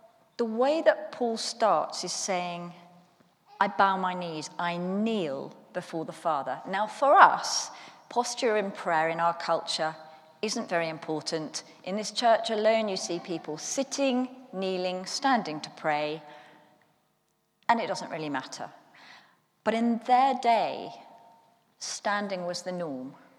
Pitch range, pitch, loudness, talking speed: 165-230 Hz, 190 Hz, -28 LUFS, 135 wpm